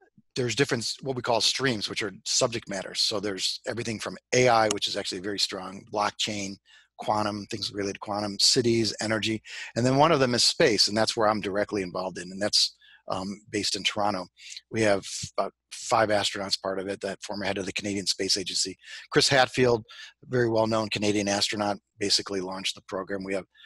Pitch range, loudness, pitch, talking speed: 100-115 Hz, -26 LUFS, 105 Hz, 195 wpm